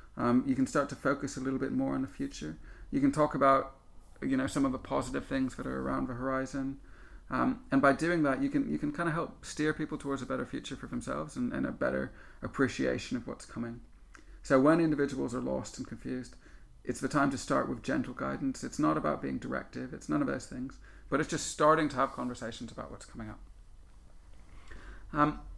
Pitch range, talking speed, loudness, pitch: 95-145 Hz, 220 wpm, -32 LUFS, 130 Hz